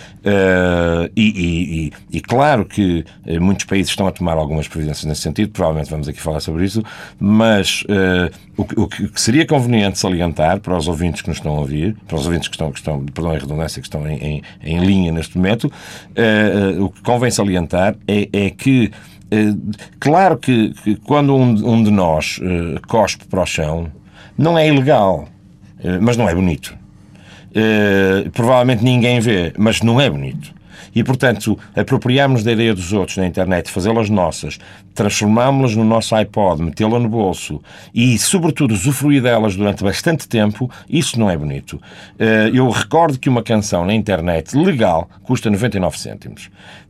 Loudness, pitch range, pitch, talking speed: -16 LUFS, 90-115 Hz, 100 Hz, 175 wpm